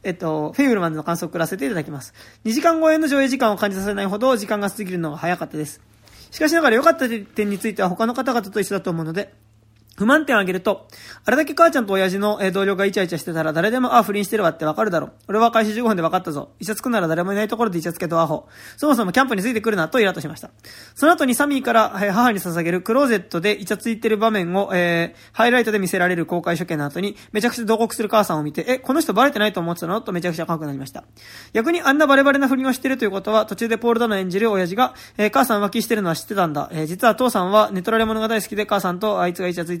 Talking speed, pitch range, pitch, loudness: 570 characters per minute, 175-230 Hz, 210 Hz, -20 LUFS